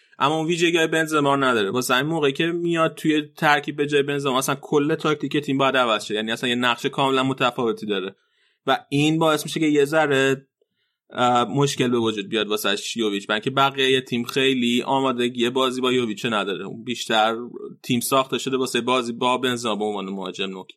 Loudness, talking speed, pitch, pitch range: -21 LUFS, 185 wpm, 130 Hz, 120-145 Hz